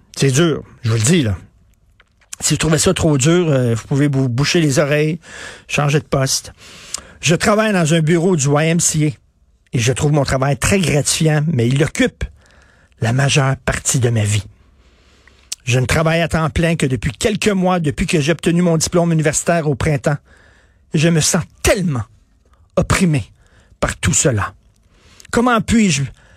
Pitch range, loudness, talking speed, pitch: 110-165 Hz, -16 LUFS, 170 wpm, 145 Hz